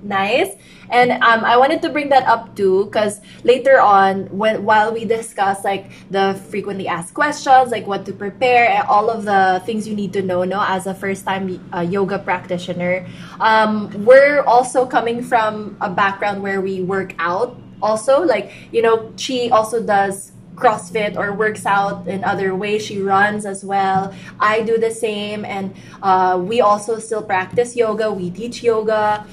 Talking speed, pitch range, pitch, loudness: 175 wpm, 195-230 Hz, 205 Hz, -17 LUFS